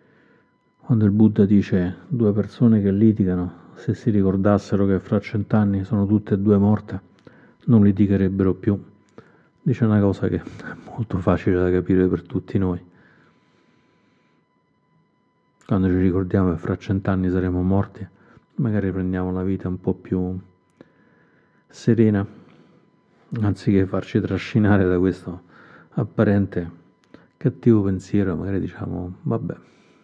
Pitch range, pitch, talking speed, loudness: 90-105 Hz, 95 Hz, 120 wpm, -21 LUFS